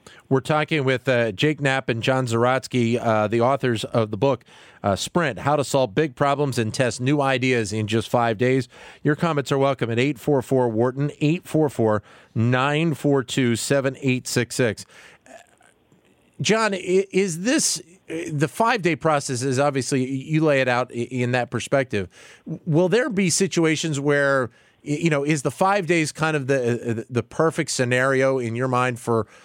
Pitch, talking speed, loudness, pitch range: 135 Hz, 155 wpm, -22 LUFS, 125-155 Hz